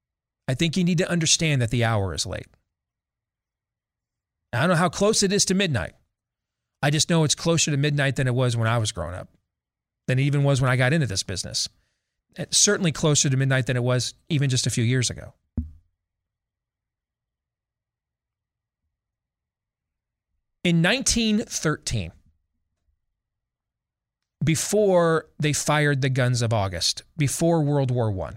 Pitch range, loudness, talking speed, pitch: 105-155 Hz, -22 LUFS, 150 wpm, 130 Hz